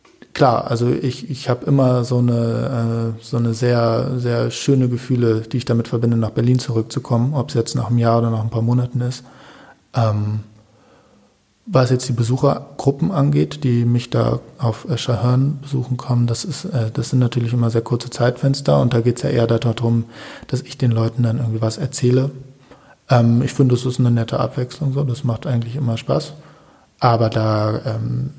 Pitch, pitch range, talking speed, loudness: 120 Hz, 115-130 Hz, 175 wpm, -19 LUFS